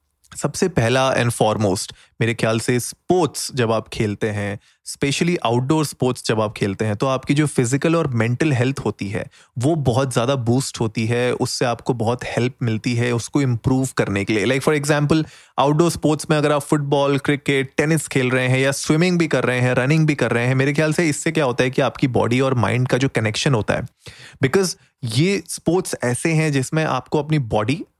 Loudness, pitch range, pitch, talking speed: -19 LUFS, 120-150 Hz, 130 Hz, 205 wpm